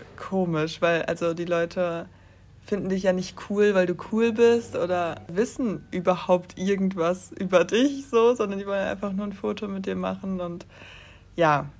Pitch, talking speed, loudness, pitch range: 180 Hz, 170 wpm, -25 LUFS, 165-205 Hz